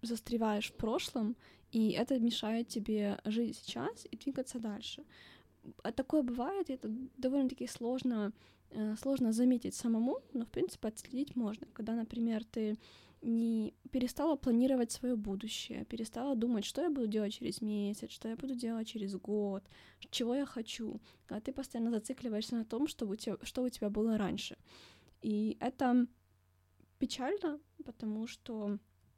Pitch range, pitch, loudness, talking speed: 215-255 Hz, 235 Hz, -37 LUFS, 145 wpm